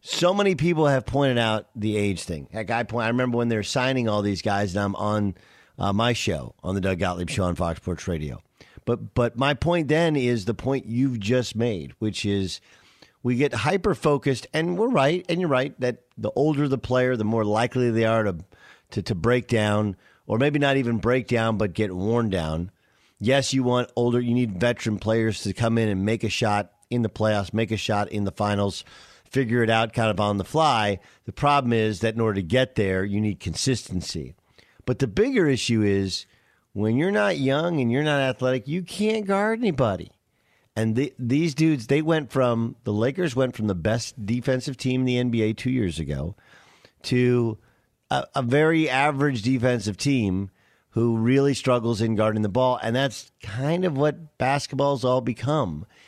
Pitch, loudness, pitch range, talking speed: 120 Hz, -24 LUFS, 105-135 Hz, 200 wpm